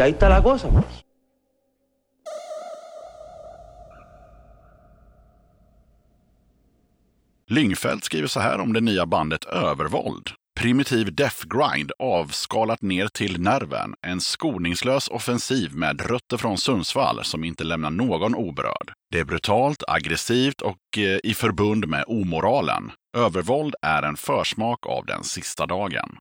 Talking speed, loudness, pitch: 105 wpm, -23 LUFS, 120 Hz